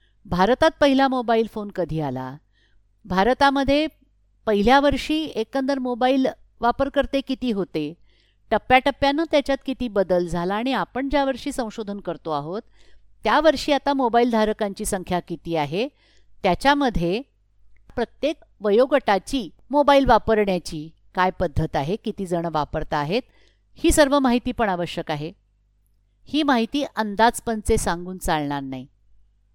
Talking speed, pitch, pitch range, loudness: 115 wpm, 220 Hz, 175-270 Hz, -22 LUFS